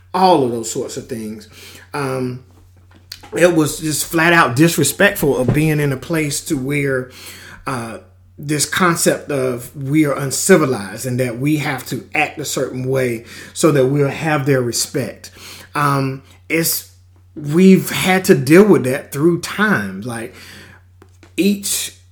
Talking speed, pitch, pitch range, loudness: 145 wpm, 130 Hz, 105-155 Hz, -16 LUFS